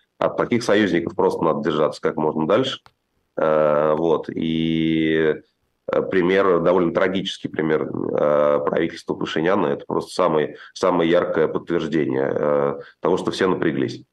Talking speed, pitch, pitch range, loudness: 115 wpm, 75 Hz, 75-80 Hz, -21 LUFS